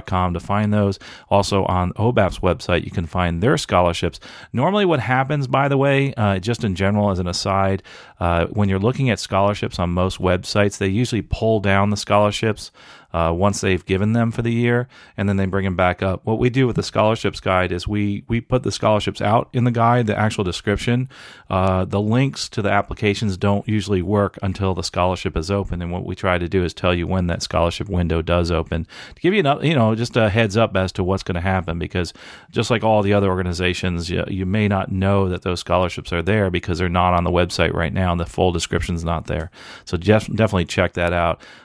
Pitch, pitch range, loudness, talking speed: 100 Hz, 90-110 Hz, -20 LUFS, 225 wpm